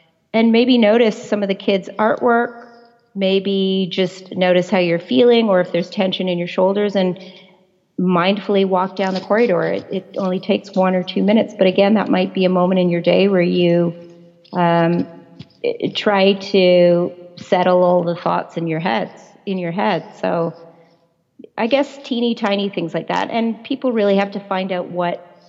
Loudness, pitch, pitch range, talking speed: -17 LUFS, 190 Hz, 180-205 Hz, 180 wpm